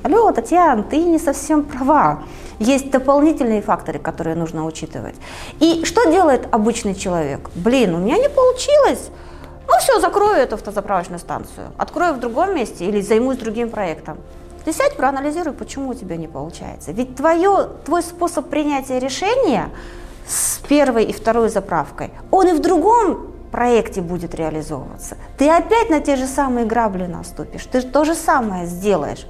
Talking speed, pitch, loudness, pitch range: 155 wpm, 260 Hz, -17 LUFS, 205-320 Hz